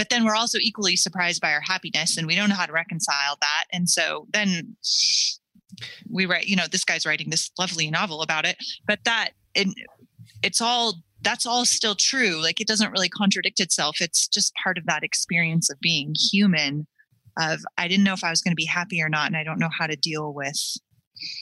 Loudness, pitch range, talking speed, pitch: -22 LUFS, 160-210 Hz, 215 wpm, 180 Hz